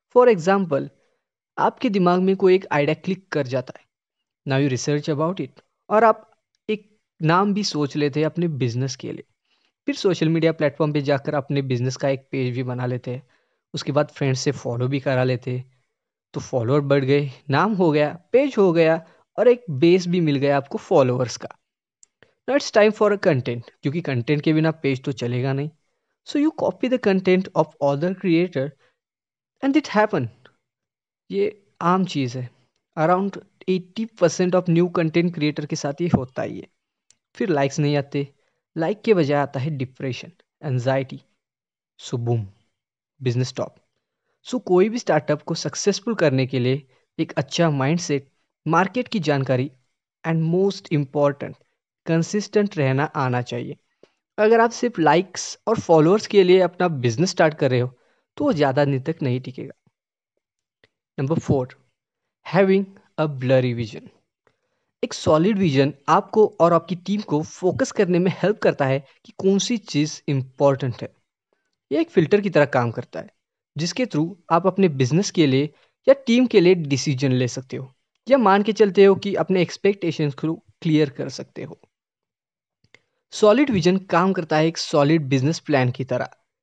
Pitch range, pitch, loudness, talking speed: 135-190 Hz, 155 Hz, -21 LUFS, 170 wpm